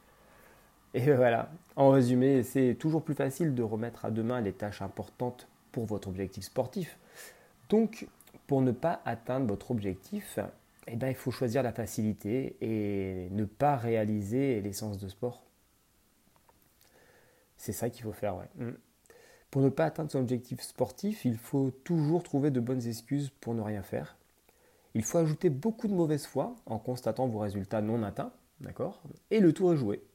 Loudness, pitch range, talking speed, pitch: -32 LUFS, 110-140 Hz, 165 wpm, 125 Hz